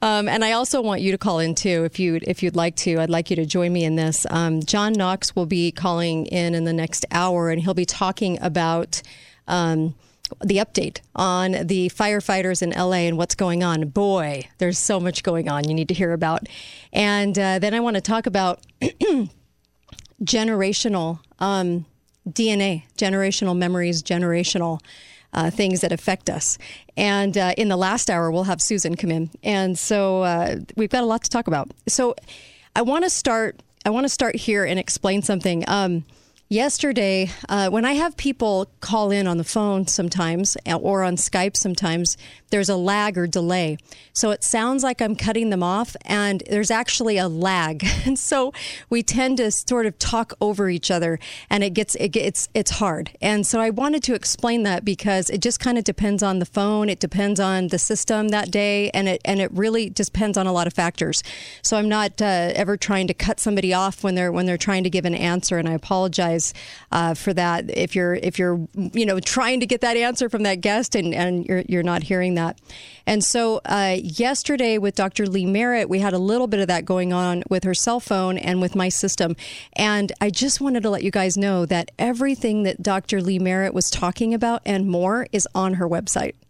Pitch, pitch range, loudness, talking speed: 190 Hz, 175-215 Hz, -21 LUFS, 205 wpm